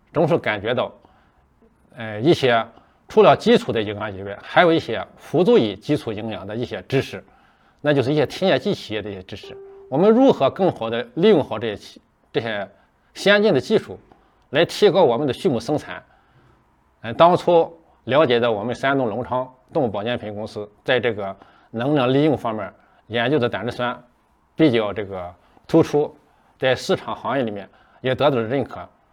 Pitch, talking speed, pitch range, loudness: 125 Hz, 270 characters per minute, 105-150 Hz, -20 LUFS